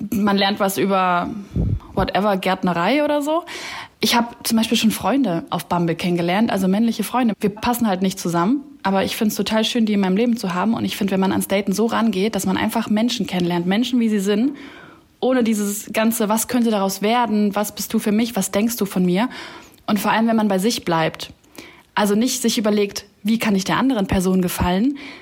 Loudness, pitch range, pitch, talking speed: -19 LUFS, 195-235 Hz, 210 Hz, 215 wpm